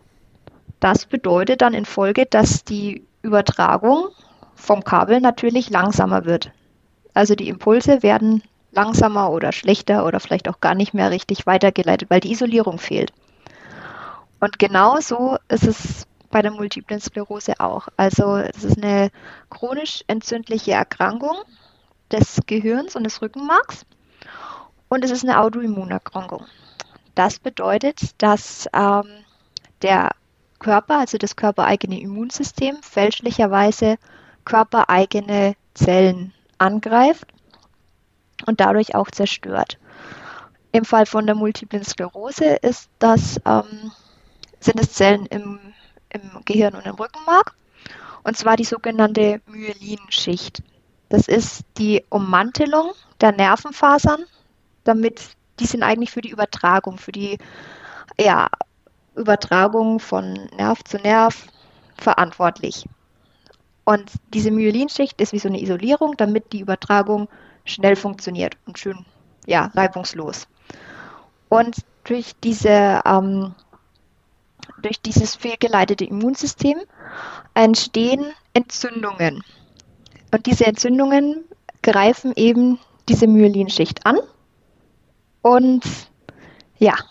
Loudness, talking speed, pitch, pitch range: -18 LUFS, 110 wpm, 215 Hz, 200-235 Hz